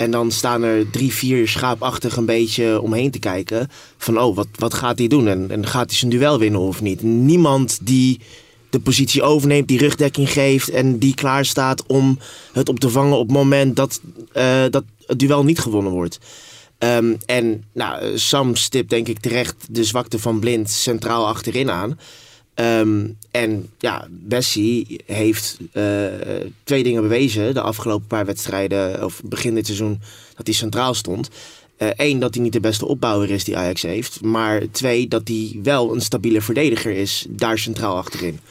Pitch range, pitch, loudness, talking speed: 110-130 Hz, 115 Hz, -18 LUFS, 180 wpm